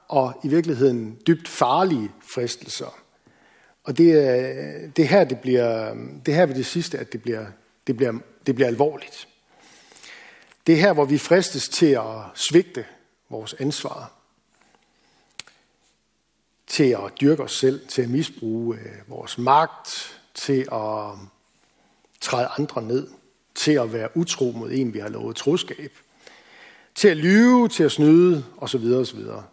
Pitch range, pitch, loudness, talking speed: 115-160 Hz, 135 Hz, -21 LUFS, 145 wpm